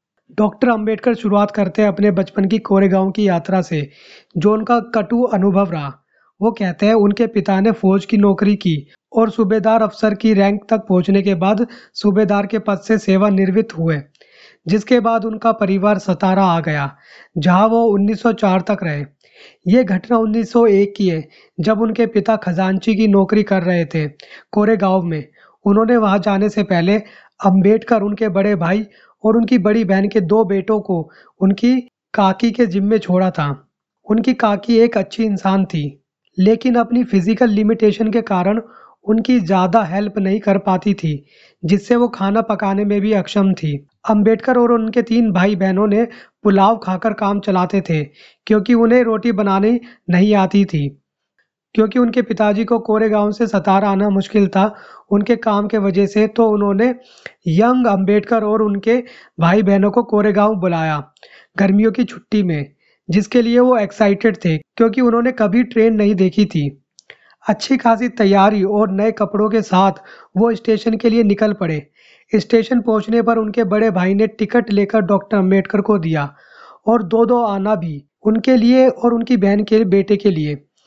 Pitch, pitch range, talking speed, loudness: 210 Hz, 195-225 Hz, 165 wpm, -15 LUFS